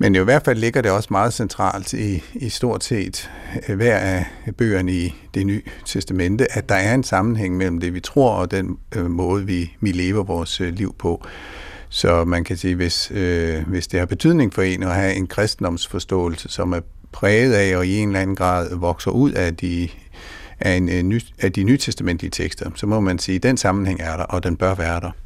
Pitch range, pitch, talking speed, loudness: 90-100 Hz, 95 Hz, 210 wpm, -20 LUFS